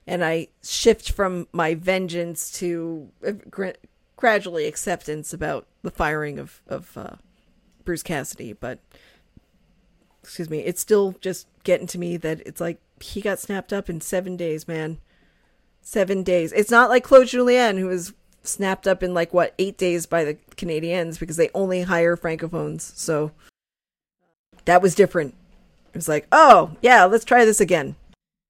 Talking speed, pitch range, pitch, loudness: 155 wpm, 165-195 Hz, 180 Hz, -20 LUFS